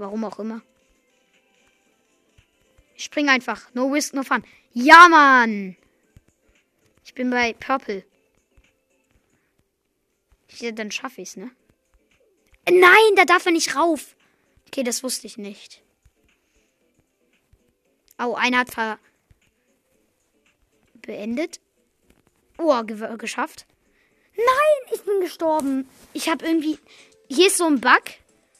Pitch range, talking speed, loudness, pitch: 230-325 Hz, 110 wpm, -18 LUFS, 265 Hz